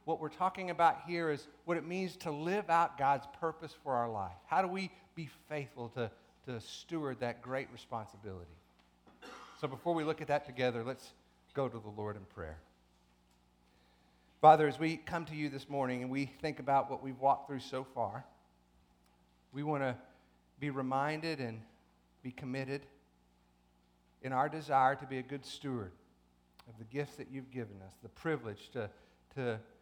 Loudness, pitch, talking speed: -36 LUFS, 130 Hz, 175 wpm